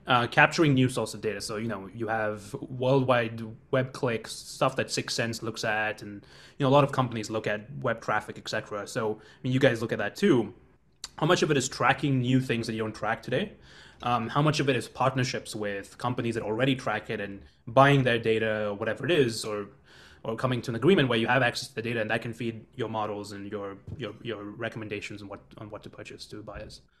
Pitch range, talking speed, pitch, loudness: 110-130 Hz, 240 wpm, 115 Hz, -28 LUFS